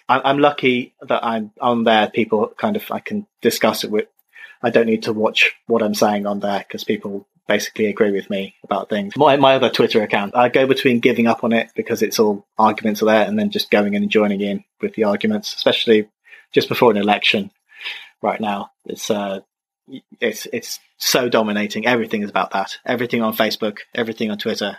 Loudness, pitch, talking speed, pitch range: -18 LUFS, 115 Hz, 205 wpm, 105-135 Hz